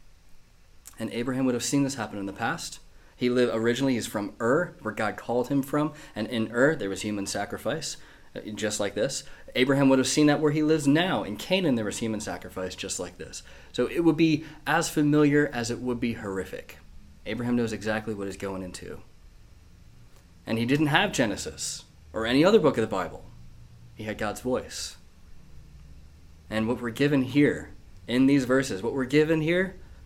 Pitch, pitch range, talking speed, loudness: 120 Hz, 95-140 Hz, 190 wpm, -26 LUFS